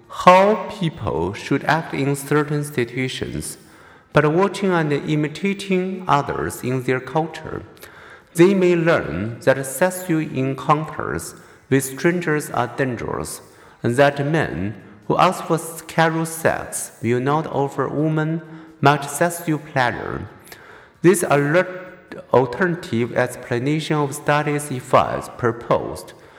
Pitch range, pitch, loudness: 135-170 Hz, 150 Hz, -20 LUFS